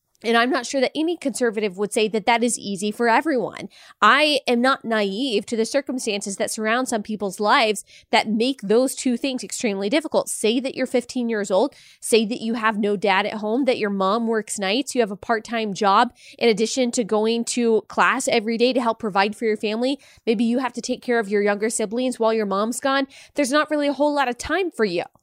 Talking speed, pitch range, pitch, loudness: 230 wpm, 215-255 Hz, 230 Hz, -21 LUFS